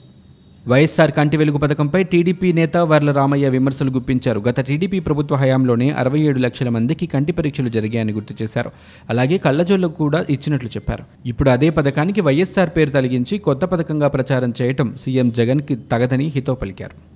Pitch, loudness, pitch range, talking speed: 140 Hz, -18 LUFS, 125-155 Hz, 150 wpm